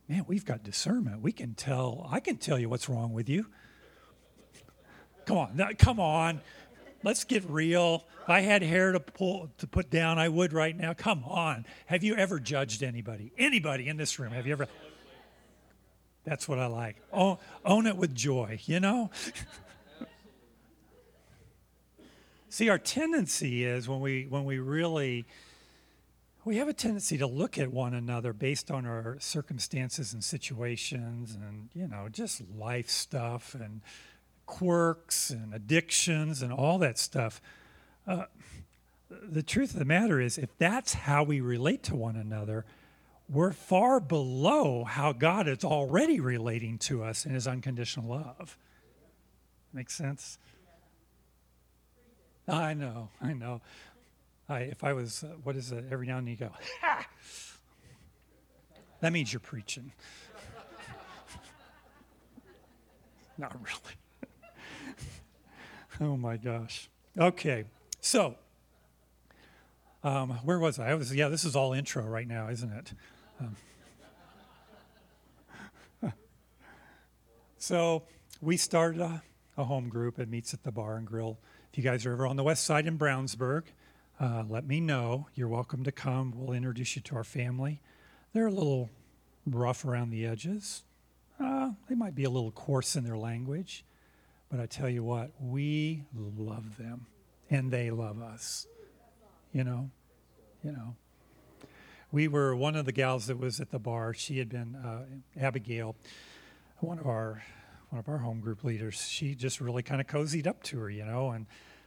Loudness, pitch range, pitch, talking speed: -32 LUFS, 115-160 Hz, 130 Hz, 150 wpm